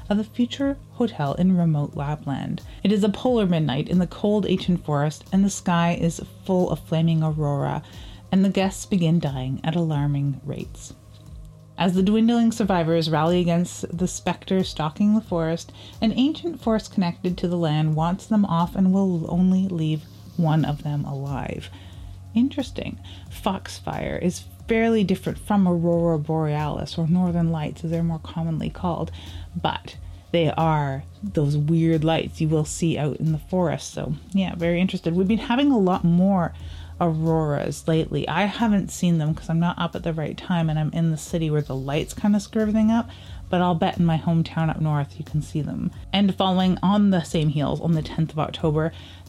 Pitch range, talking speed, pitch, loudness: 150-190 Hz, 185 wpm, 165 Hz, -23 LUFS